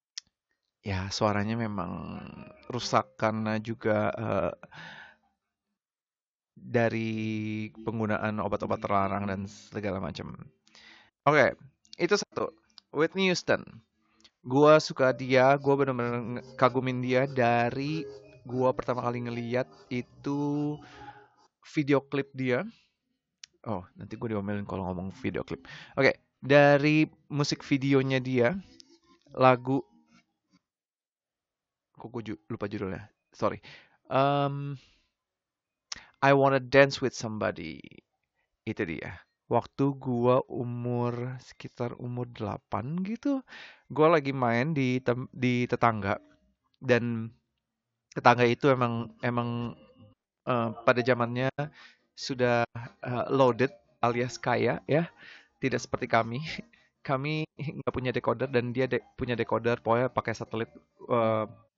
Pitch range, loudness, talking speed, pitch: 115-140 Hz, -28 LUFS, 105 wpm, 125 Hz